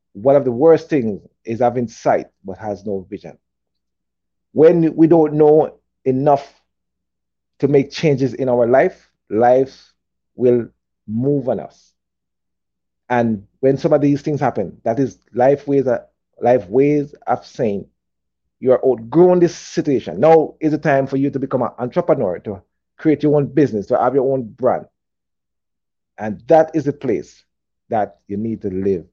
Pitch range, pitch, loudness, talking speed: 100-150 Hz, 130 Hz, -17 LUFS, 165 wpm